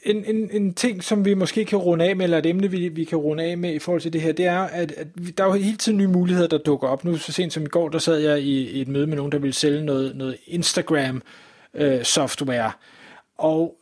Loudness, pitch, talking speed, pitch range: -22 LUFS, 165 Hz, 270 wpm, 150-180 Hz